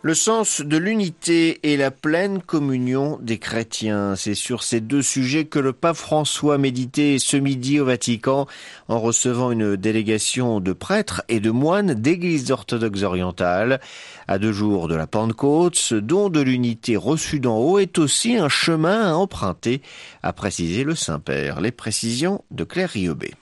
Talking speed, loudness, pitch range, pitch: 165 wpm, -20 LUFS, 110-155 Hz, 130 Hz